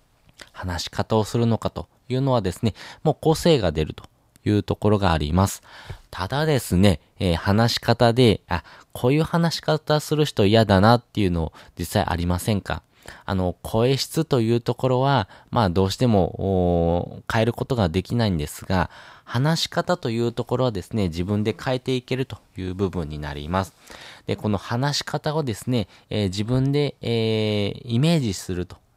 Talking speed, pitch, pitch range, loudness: 330 characters per minute, 110 Hz, 95-125 Hz, -23 LUFS